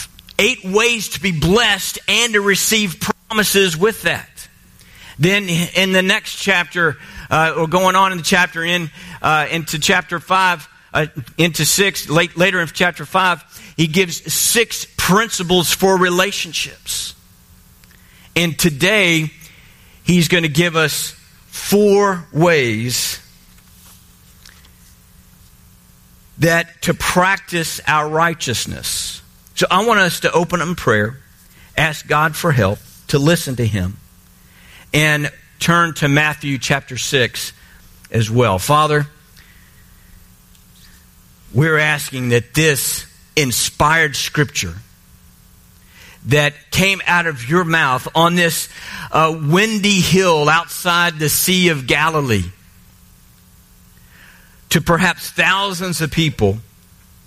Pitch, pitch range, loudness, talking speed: 160 Hz, 140-180 Hz, -15 LUFS, 115 wpm